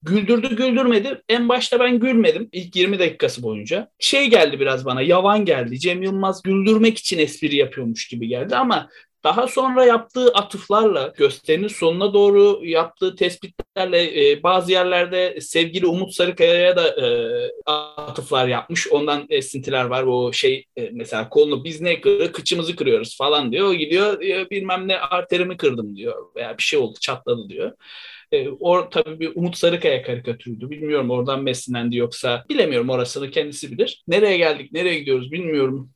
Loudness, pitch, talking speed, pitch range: -19 LUFS, 185 Hz, 155 wpm, 150-240 Hz